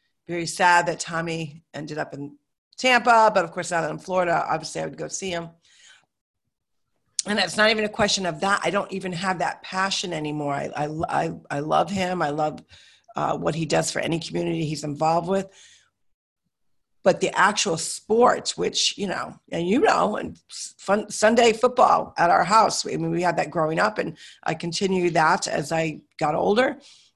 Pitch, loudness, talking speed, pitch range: 175 Hz, -23 LUFS, 190 wpm, 160-195 Hz